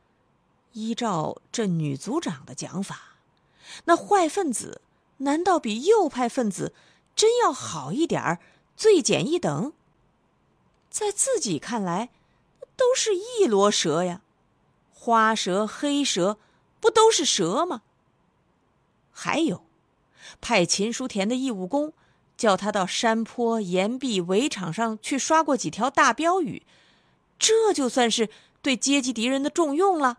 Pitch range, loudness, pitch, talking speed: 210-330 Hz, -24 LUFS, 250 Hz, 180 characters per minute